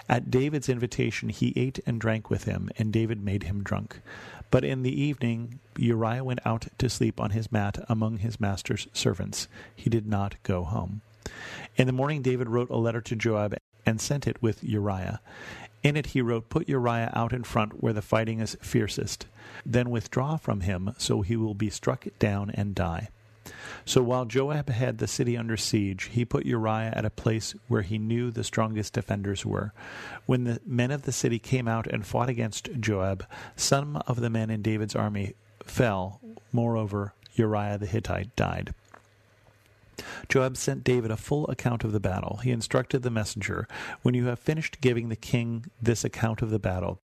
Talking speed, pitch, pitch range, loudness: 185 wpm, 115 Hz, 105-125 Hz, -28 LUFS